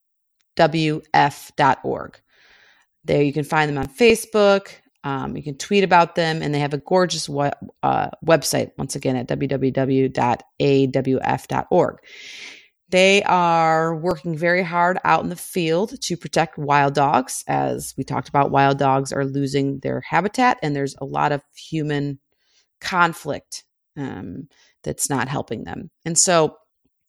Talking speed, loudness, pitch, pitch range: 140 wpm, -20 LUFS, 155 Hz, 140-175 Hz